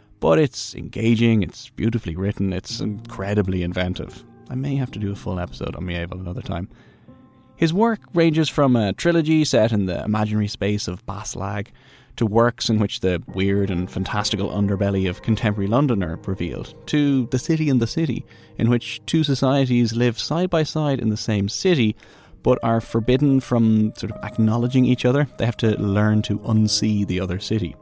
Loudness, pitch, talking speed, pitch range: -21 LUFS, 110 Hz, 180 wpm, 100-130 Hz